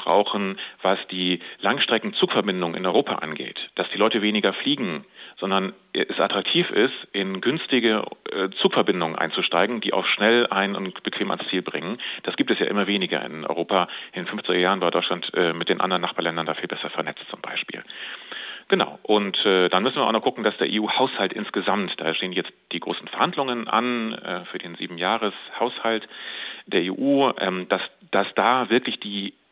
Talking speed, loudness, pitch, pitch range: 180 wpm, -23 LUFS, 100 Hz, 95-110 Hz